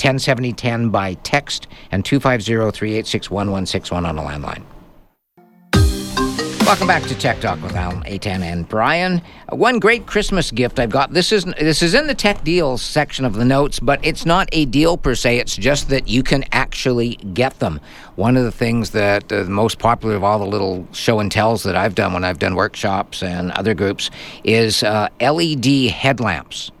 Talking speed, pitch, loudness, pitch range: 190 wpm, 115 Hz, -17 LUFS, 100-140 Hz